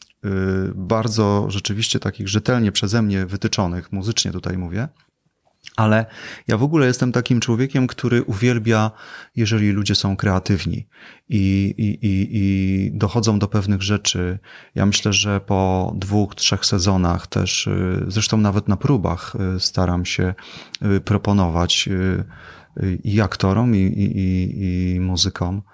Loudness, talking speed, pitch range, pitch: -20 LUFS, 120 wpm, 95-110 Hz, 100 Hz